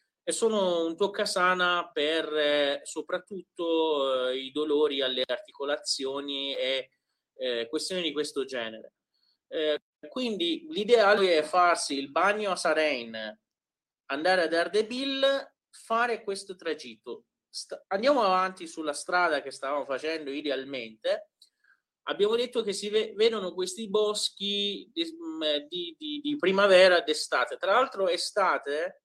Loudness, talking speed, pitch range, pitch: -27 LUFS, 125 wpm, 150-215 Hz, 180 Hz